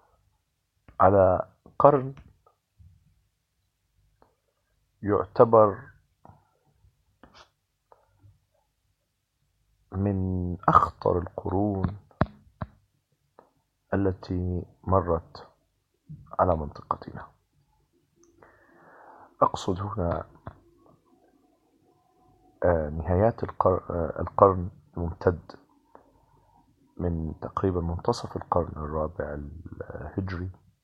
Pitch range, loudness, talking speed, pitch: 85-100 Hz, -26 LUFS, 40 wpm, 95 Hz